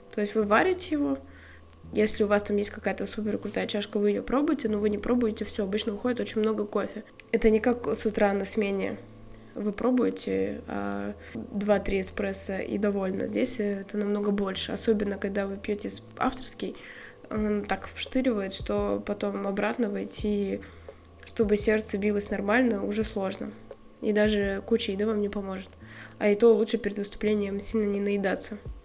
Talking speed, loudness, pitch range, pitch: 165 wpm, -27 LUFS, 195-220 Hz, 205 Hz